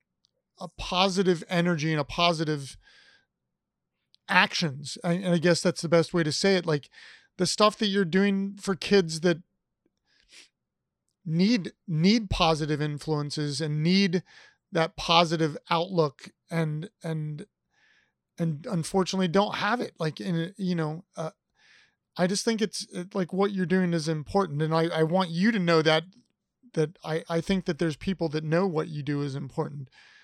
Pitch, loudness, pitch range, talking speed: 170 Hz, -26 LUFS, 160-195 Hz, 160 wpm